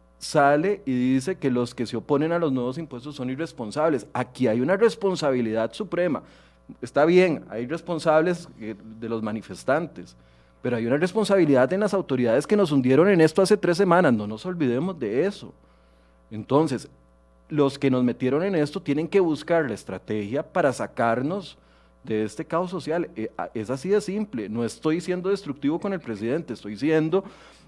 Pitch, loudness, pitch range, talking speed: 140 Hz, -24 LUFS, 115-175 Hz, 165 wpm